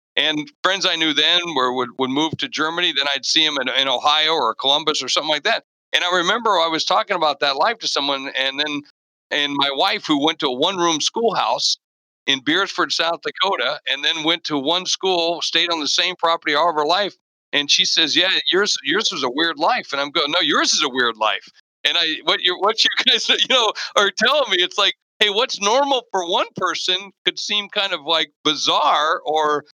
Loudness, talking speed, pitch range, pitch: -18 LUFS, 225 wpm, 150-185 Hz, 165 Hz